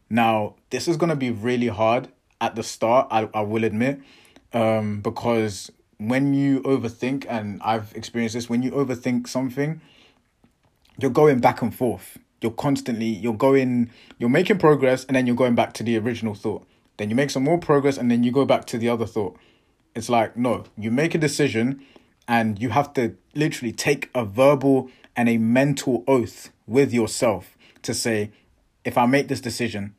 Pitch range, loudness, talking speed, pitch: 115-135 Hz, -22 LUFS, 185 wpm, 120 Hz